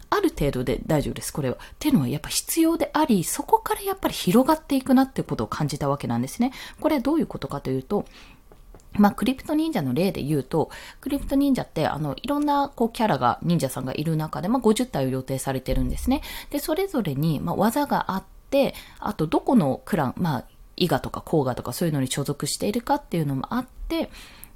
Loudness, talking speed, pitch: -24 LUFS, 445 characters per minute, 235 Hz